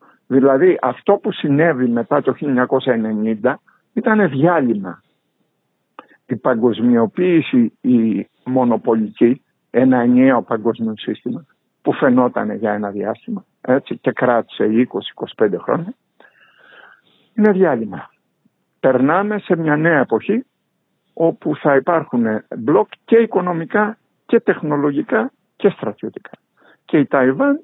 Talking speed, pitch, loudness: 100 wpm, 165 Hz, -17 LUFS